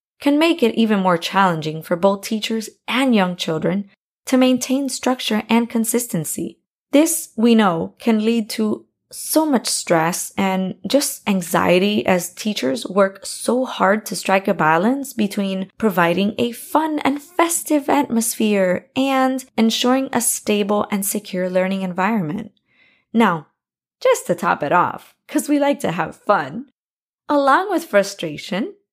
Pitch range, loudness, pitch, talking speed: 190-260 Hz, -19 LUFS, 225 Hz, 140 wpm